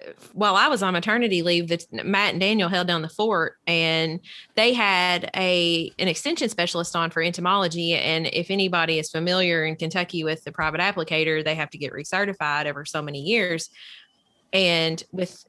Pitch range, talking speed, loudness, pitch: 160-190 Hz, 175 wpm, -22 LUFS, 170 Hz